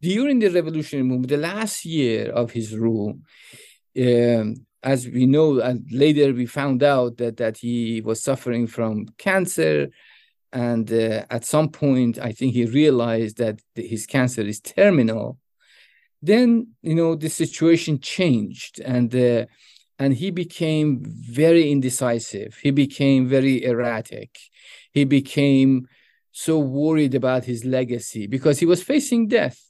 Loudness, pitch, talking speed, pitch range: -21 LUFS, 130 Hz, 140 wpm, 120-155 Hz